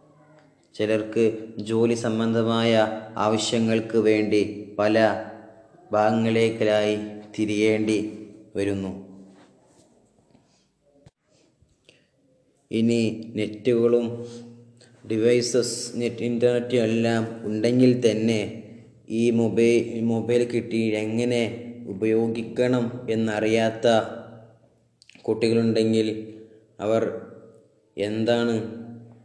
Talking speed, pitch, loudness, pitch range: 55 wpm, 115 Hz, -23 LUFS, 110-115 Hz